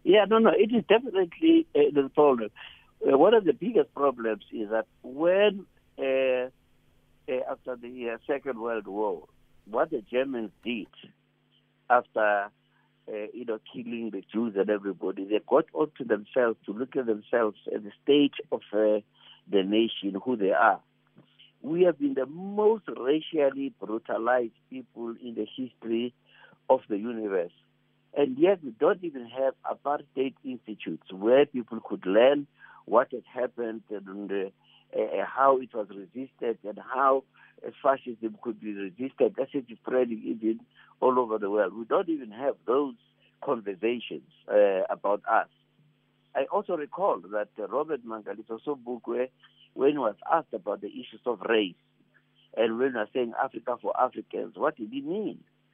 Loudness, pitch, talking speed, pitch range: -28 LUFS, 125 Hz, 160 wpm, 110-145 Hz